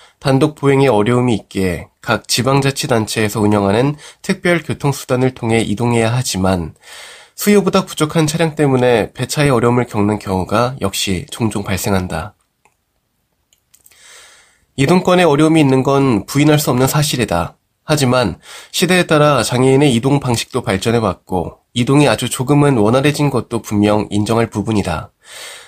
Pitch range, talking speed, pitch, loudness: 105-145 Hz, 325 characters per minute, 125 Hz, -15 LUFS